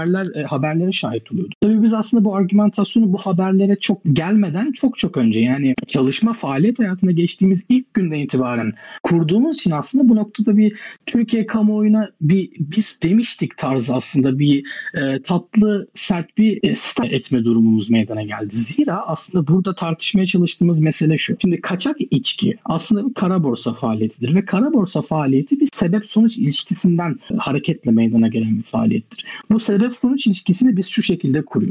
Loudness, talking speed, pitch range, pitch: -18 LUFS, 155 wpm, 145-215 Hz, 190 Hz